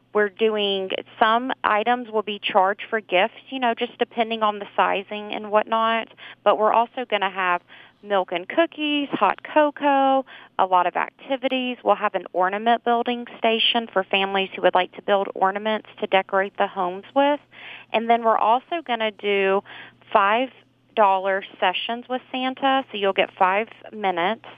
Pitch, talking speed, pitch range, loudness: 215 Hz, 165 wpm, 195-240 Hz, -22 LUFS